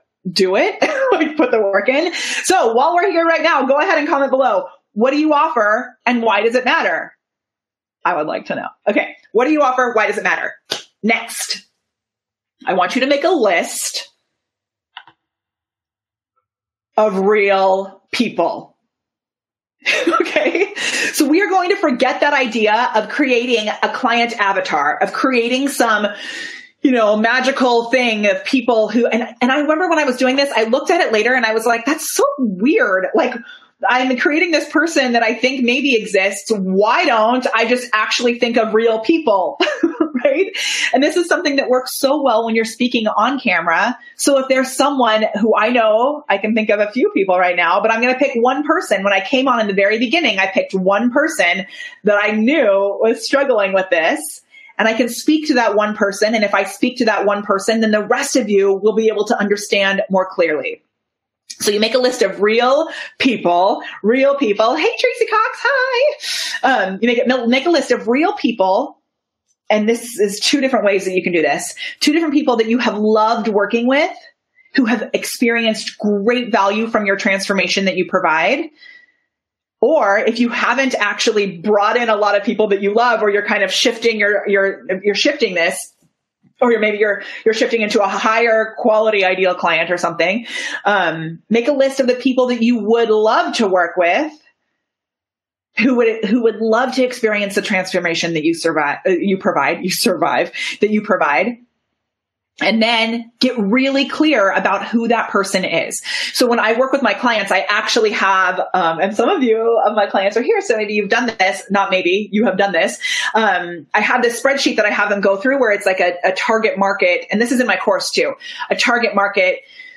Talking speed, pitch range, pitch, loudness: 200 wpm, 205-275 Hz, 230 Hz, -15 LUFS